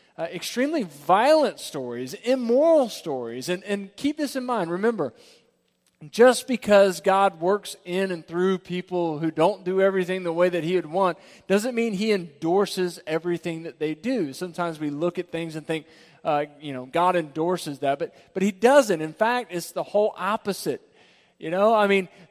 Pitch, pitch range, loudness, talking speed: 180 Hz, 165-205 Hz, -24 LUFS, 180 wpm